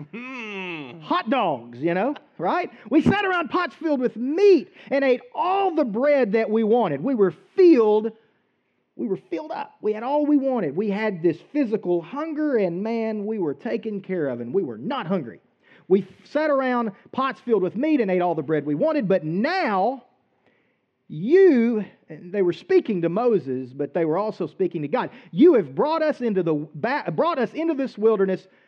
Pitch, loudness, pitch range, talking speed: 220 Hz, -22 LUFS, 185-280 Hz, 190 wpm